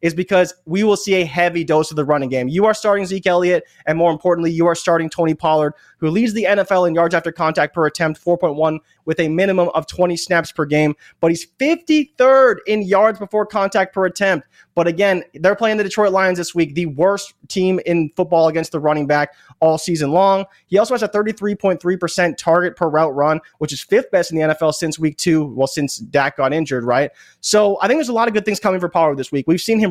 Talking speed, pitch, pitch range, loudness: 235 wpm, 175 Hz, 160-195 Hz, -17 LUFS